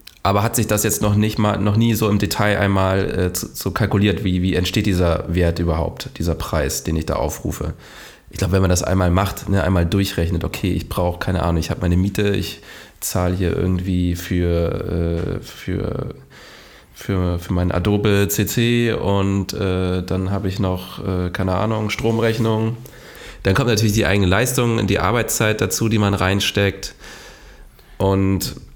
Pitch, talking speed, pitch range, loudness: 95 Hz, 175 wpm, 90-105 Hz, -19 LUFS